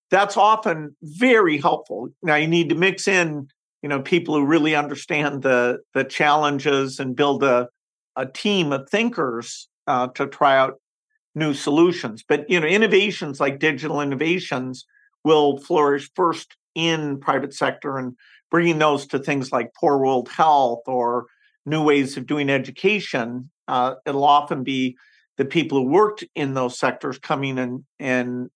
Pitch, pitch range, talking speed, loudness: 145 Hz, 135-165 Hz, 160 wpm, -20 LUFS